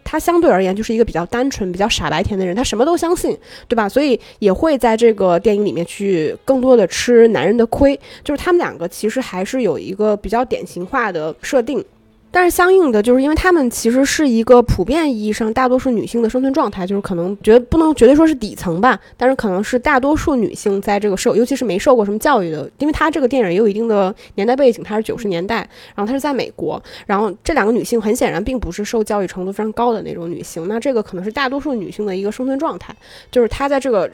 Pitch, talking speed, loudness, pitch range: 230 Hz, 385 characters per minute, -16 LUFS, 205-265 Hz